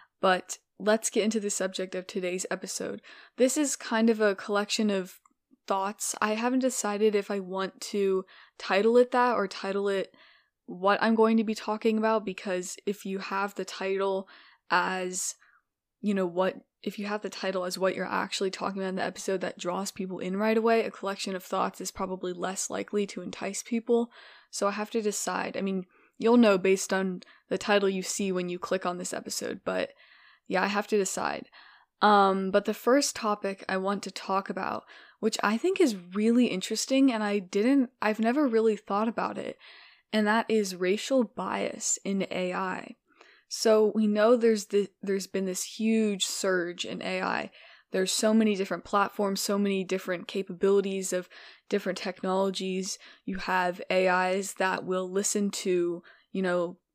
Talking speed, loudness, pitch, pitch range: 180 wpm, -28 LUFS, 200 Hz, 190-220 Hz